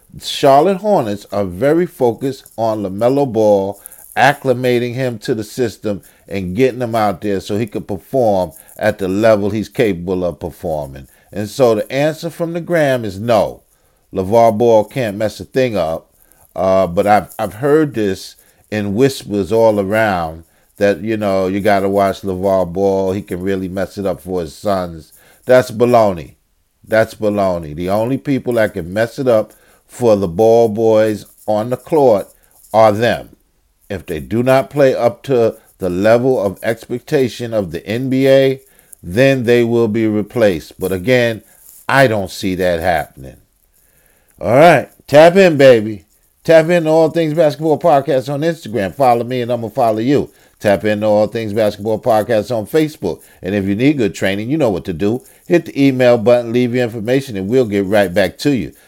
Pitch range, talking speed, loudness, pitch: 100-130 Hz, 175 wpm, -15 LUFS, 110 Hz